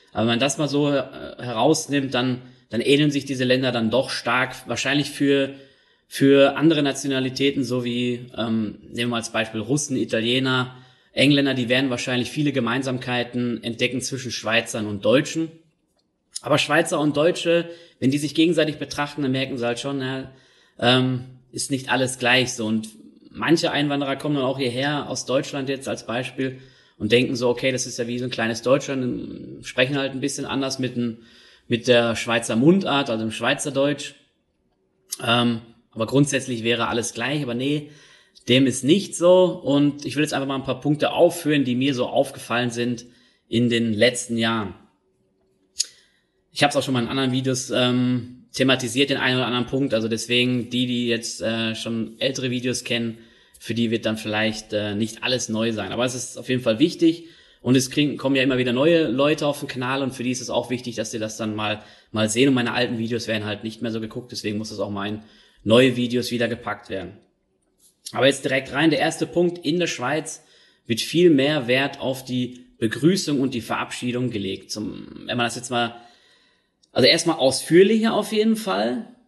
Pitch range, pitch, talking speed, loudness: 120-140 Hz, 125 Hz, 195 wpm, -22 LUFS